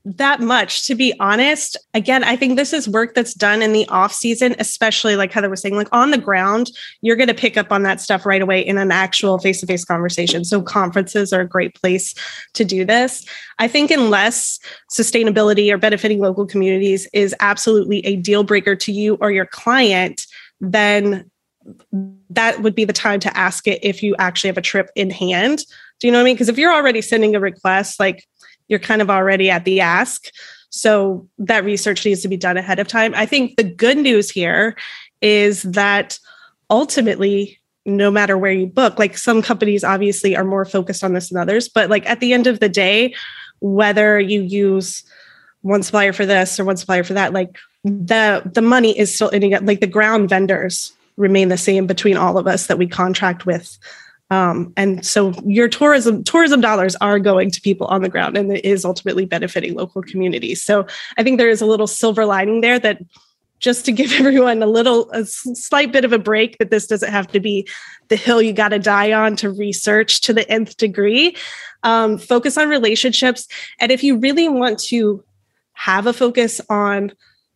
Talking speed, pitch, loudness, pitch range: 205 wpm, 205 Hz, -15 LUFS, 195-230 Hz